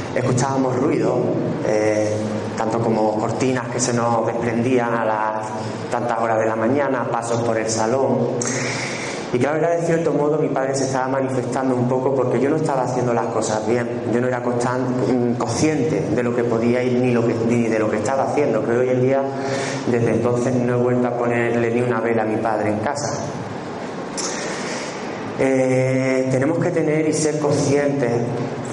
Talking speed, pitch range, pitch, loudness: 185 wpm, 115-135 Hz, 125 Hz, -20 LUFS